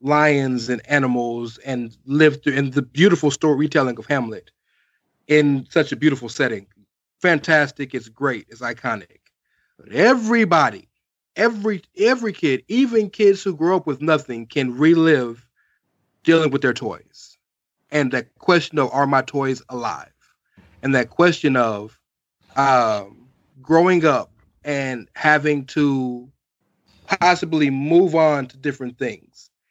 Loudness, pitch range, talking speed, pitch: -19 LUFS, 130-160 Hz, 125 wpm, 145 Hz